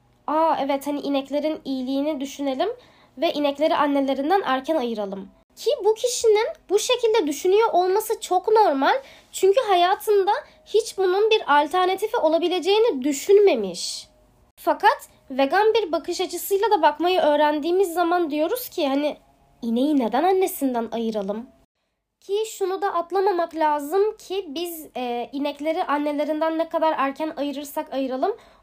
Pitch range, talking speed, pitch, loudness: 290-395 Hz, 125 wpm, 330 Hz, -22 LUFS